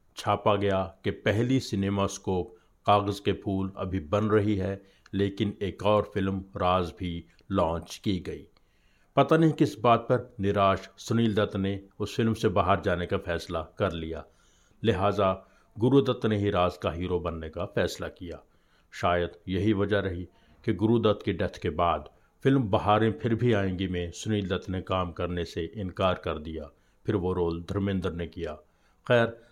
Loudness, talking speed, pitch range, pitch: -28 LUFS, 165 wpm, 90-105 Hz, 100 Hz